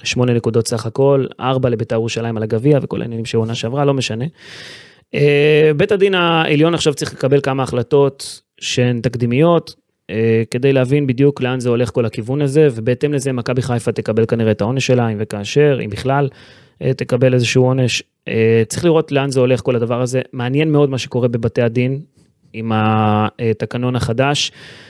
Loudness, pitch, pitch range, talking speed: -16 LUFS, 125 Hz, 115-140 Hz, 165 wpm